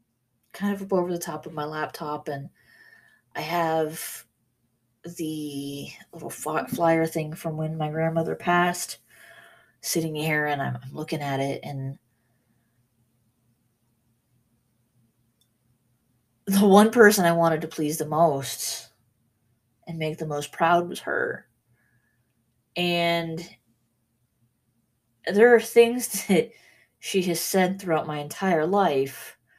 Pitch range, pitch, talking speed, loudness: 120-170 Hz, 145 Hz, 115 wpm, -24 LUFS